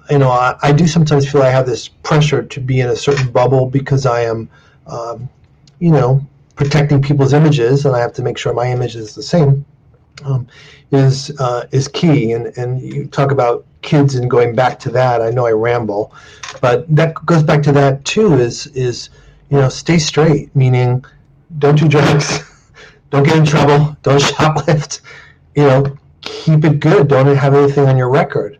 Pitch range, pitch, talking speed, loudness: 125-145 Hz, 140 Hz, 190 wpm, -13 LUFS